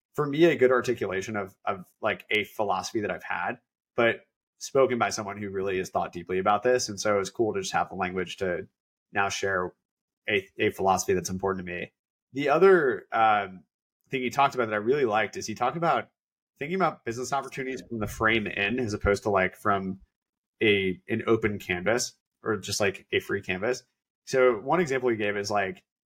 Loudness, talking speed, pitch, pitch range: -27 LUFS, 205 wpm, 110 Hz, 100-130 Hz